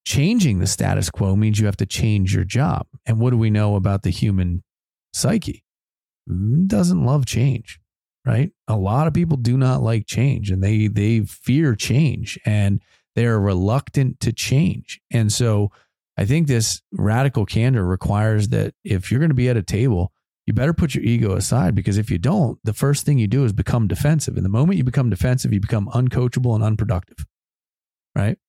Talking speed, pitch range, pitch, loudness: 190 wpm, 100-130 Hz, 115 Hz, -20 LUFS